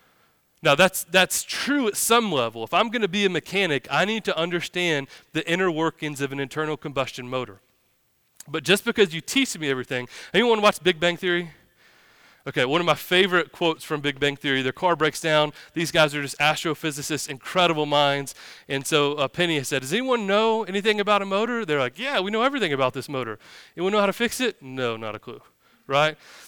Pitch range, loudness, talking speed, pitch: 140-195 Hz, -23 LUFS, 210 wpm, 160 Hz